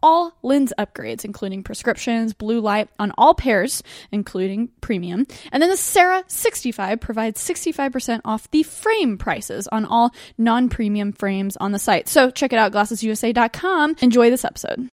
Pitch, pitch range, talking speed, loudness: 235 Hz, 215-280 Hz, 155 wpm, -20 LUFS